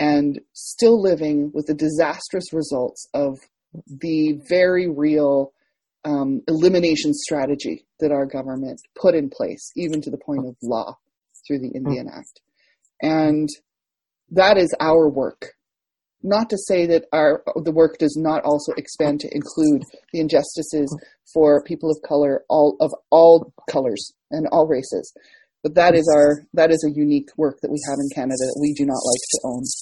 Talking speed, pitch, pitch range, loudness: 165 wpm, 150 Hz, 145-165 Hz, -19 LUFS